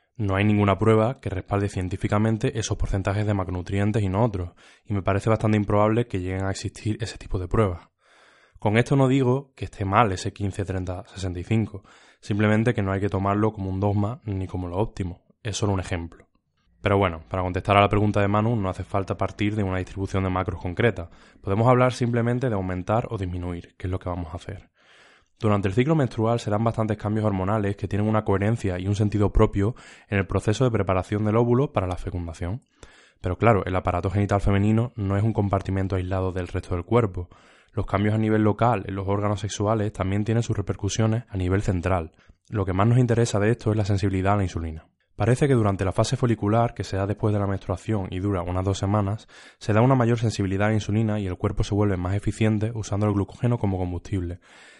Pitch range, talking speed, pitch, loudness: 95-110 Hz, 215 wpm, 100 Hz, -24 LUFS